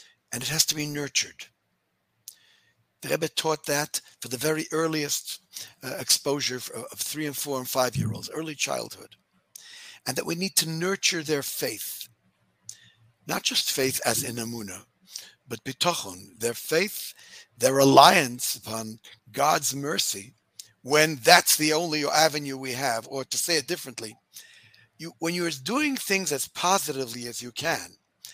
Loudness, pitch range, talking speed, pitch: -25 LUFS, 120-160 Hz, 150 wpm, 140 Hz